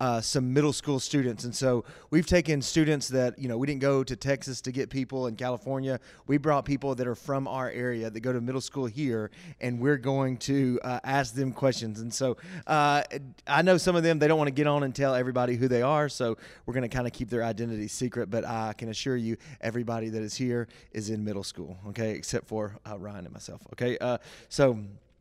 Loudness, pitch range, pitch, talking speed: -29 LUFS, 115-140 Hz, 125 Hz, 235 wpm